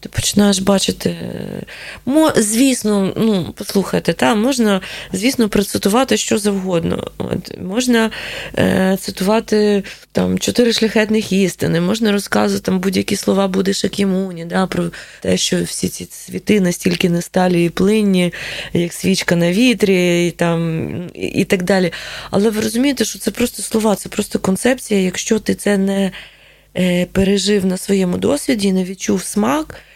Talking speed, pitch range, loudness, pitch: 145 wpm, 180-215 Hz, -16 LUFS, 195 Hz